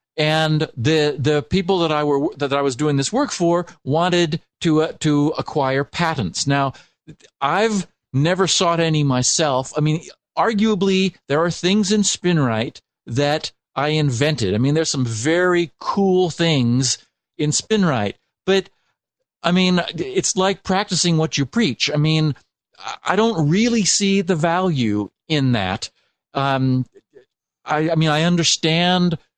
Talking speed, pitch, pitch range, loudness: 145 wpm, 160 Hz, 145-180 Hz, -19 LUFS